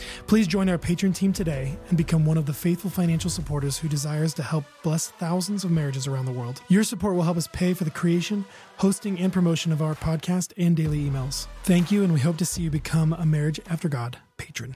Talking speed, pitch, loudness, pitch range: 230 wpm, 165 Hz, -25 LUFS, 150-180 Hz